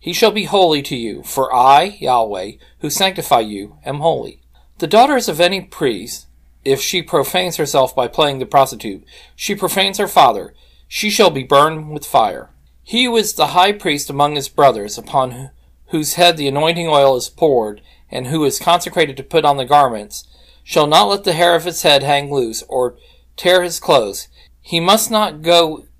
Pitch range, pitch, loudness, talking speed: 135-180 Hz, 150 Hz, -15 LUFS, 190 wpm